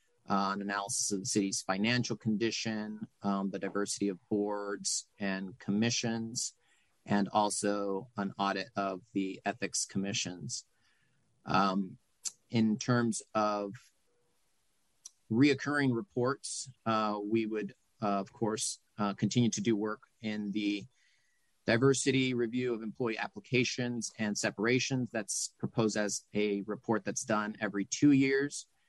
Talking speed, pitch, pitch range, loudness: 125 wpm, 105 Hz, 100-120 Hz, -33 LUFS